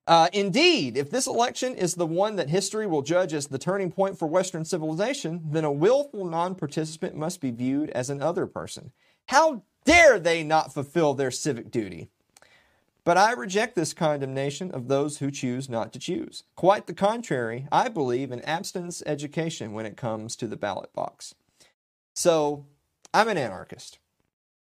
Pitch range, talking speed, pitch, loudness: 140-185 Hz, 170 wpm, 160 Hz, -25 LUFS